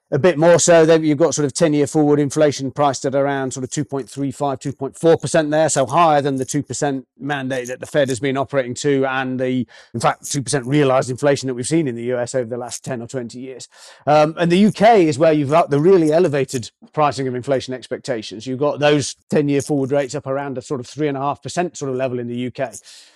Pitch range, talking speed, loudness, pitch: 130-150 Hz, 225 wpm, -18 LUFS, 140 Hz